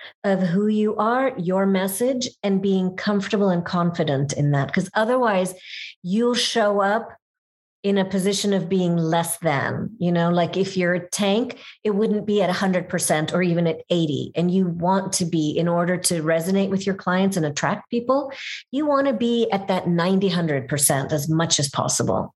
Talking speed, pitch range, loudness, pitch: 190 wpm, 170-205 Hz, -21 LUFS, 190 Hz